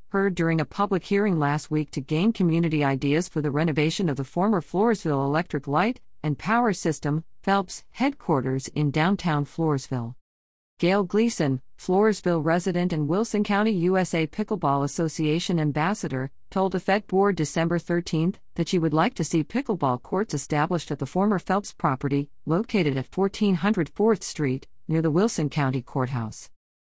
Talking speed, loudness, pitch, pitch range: 155 wpm, -25 LUFS, 165 Hz, 145-195 Hz